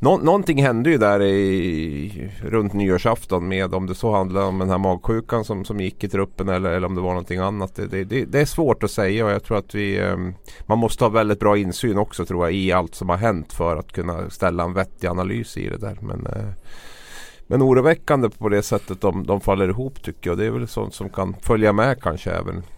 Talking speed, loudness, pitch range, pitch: 230 wpm, -21 LUFS, 95-110 Hz, 100 Hz